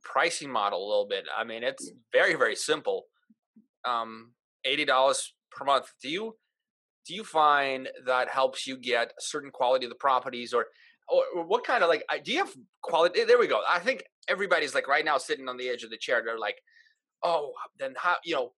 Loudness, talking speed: -28 LUFS, 205 wpm